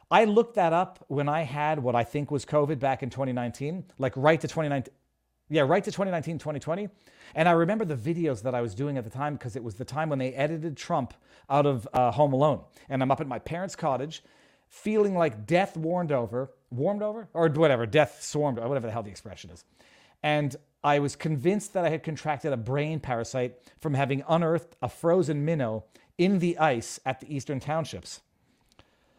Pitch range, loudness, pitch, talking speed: 130-165 Hz, -28 LUFS, 150 Hz, 200 wpm